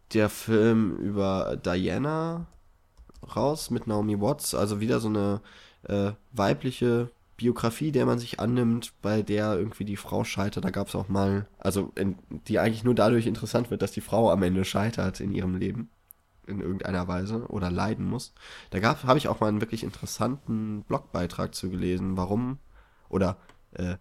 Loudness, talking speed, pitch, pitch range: -28 LUFS, 170 wpm, 105 Hz, 95-115 Hz